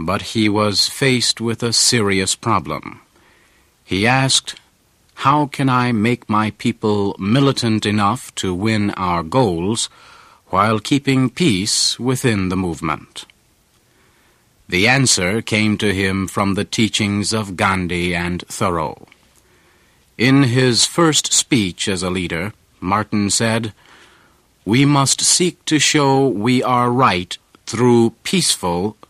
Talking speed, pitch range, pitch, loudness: 120 wpm, 100-125 Hz, 110 Hz, -16 LUFS